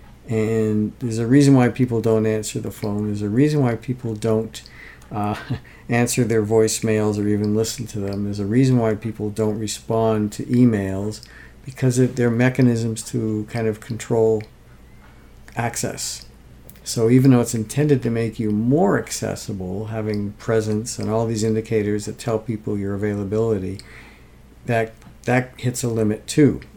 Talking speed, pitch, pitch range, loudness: 155 wpm, 110 Hz, 105-120 Hz, -21 LUFS